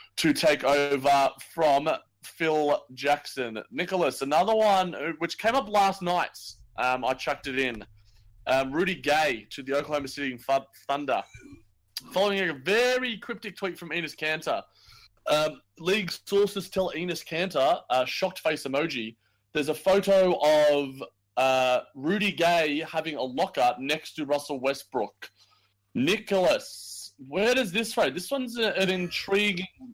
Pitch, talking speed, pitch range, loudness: 155 Hz, 135 wpm, 135-190 Hz, -26 LUFS